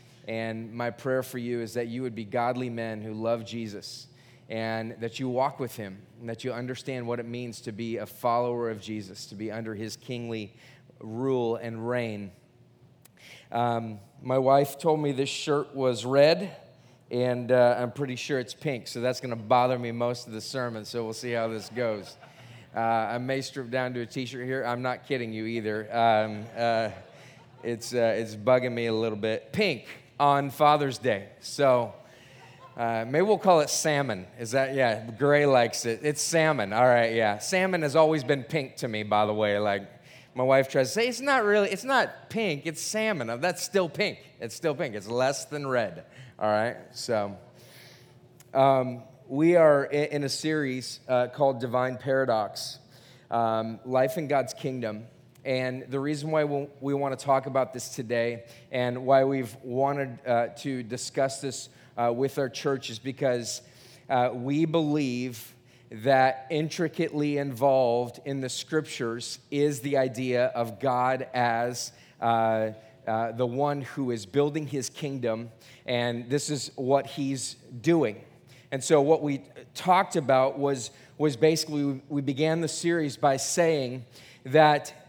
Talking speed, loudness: 170 wpm, -27 LUFS